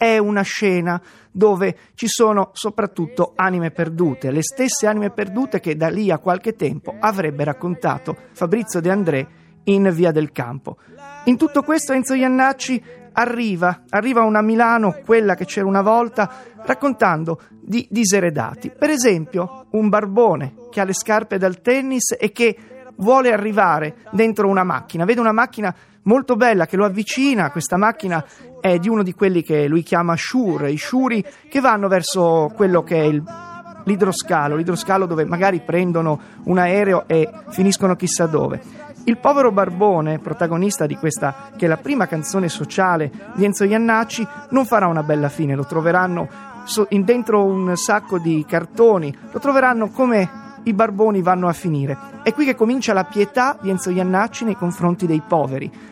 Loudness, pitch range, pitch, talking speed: -18 LUFS, 170-230 Hz, 195 Hz, 160 wpm